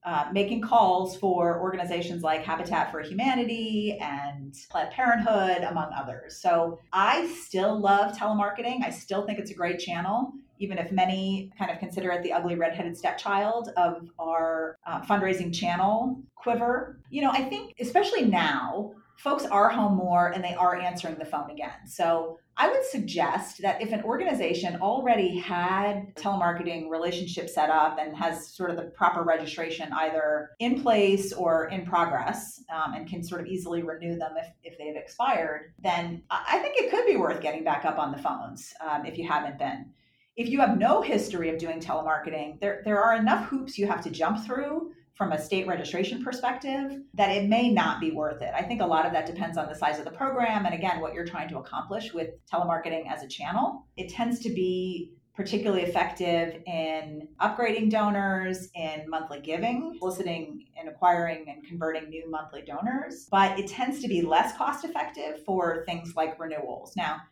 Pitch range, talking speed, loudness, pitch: 165-215 Hz, 185 wpm, -28 LUFS, 180 Hz